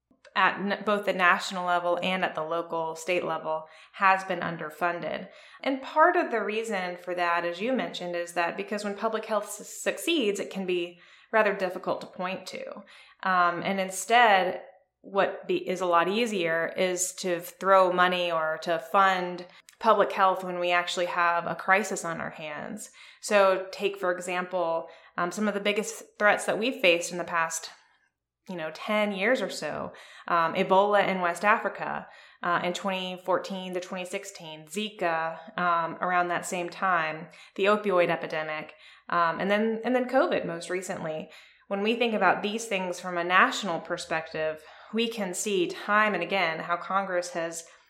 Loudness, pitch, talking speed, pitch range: -27 LUFS, 185 Hz, 170 wpm, 175-205 Hz